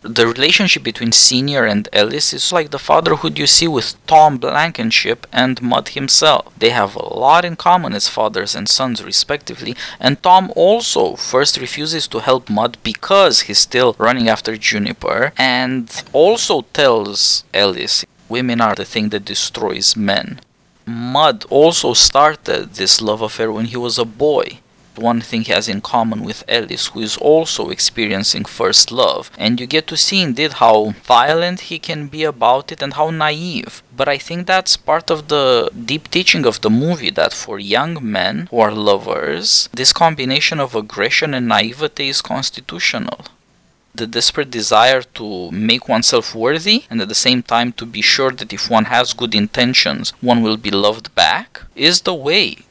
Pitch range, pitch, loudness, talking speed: 115-155 Hz, 130 Hz, -14 LUFS, 170 wpm